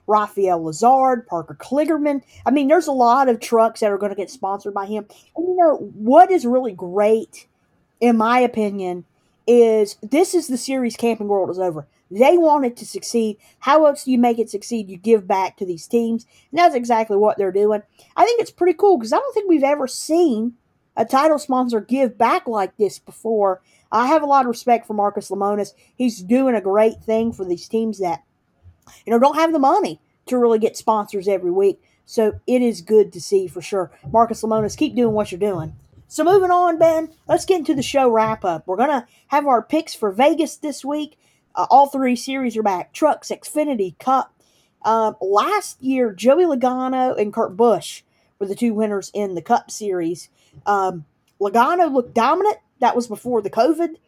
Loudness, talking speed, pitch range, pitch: -19 LUFS, 200 wpm, 205-275 Hz, 230 Hz